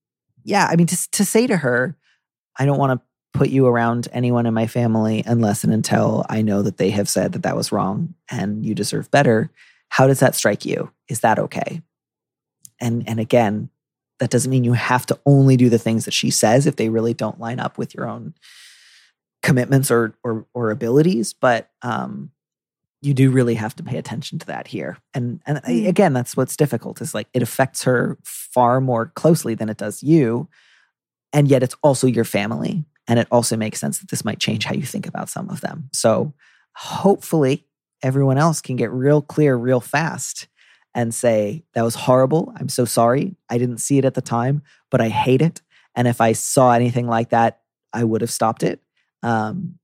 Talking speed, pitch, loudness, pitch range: 200 wpm, 125 Hz, -19 LUFS, 115-145 Hz